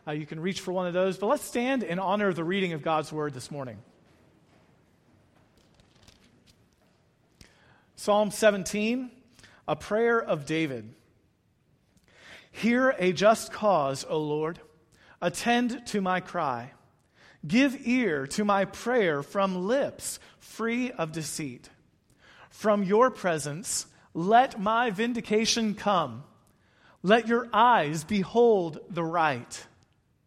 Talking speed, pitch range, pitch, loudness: 120 wpm, 155-225 Hz, 190 Hz, -27 LUFS